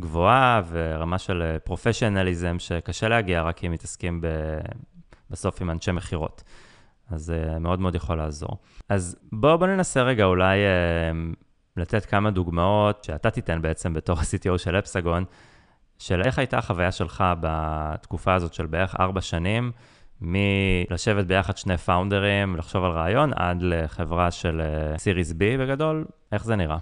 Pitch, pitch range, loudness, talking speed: 90 Hz, 85-105 Hz, -24 LUFS, 140 wpm